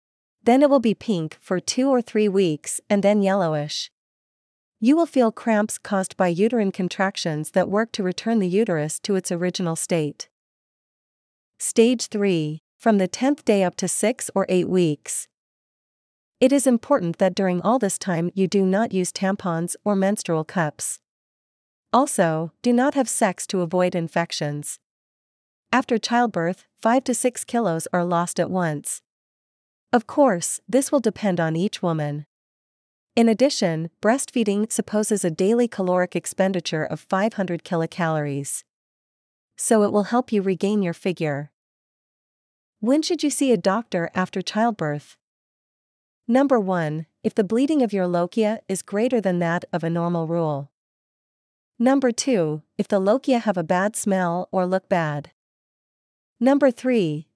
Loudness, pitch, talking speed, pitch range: -22 LUFS, 195 Hz, 150 wpm, 170-230 Hz